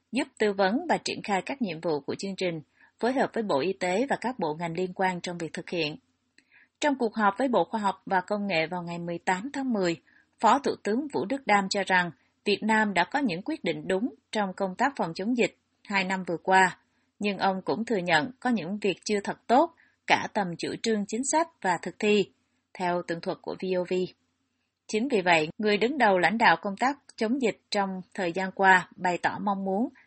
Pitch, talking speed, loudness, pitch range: 195 Hz, 230 wpm, -27 LUFS, 180-225 Hz